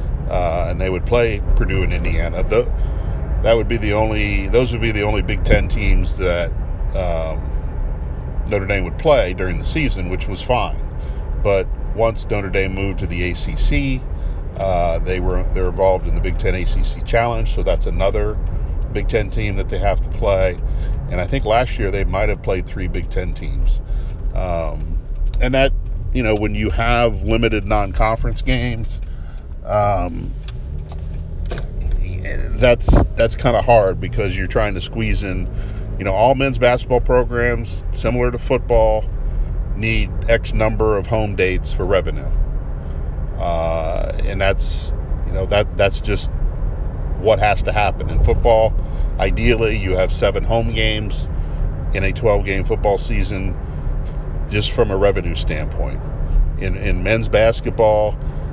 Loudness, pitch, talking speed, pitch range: -20 LUFS, 95 Hz, 155 wpm, 80-110 Hz